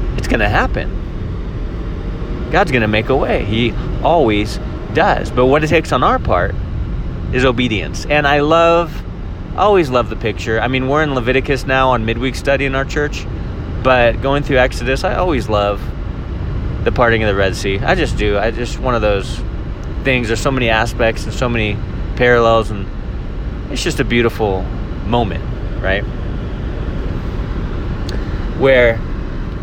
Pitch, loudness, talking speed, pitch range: 115 Hz, -16 LUFS, 160 wpm, 105-130 Hz